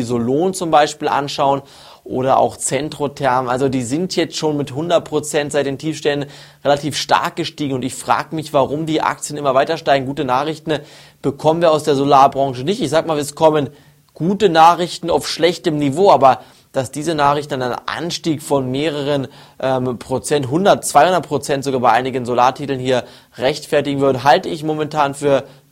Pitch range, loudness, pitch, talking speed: 135-155 Hz, -17 LUFS, 145 Hz, 170 wpm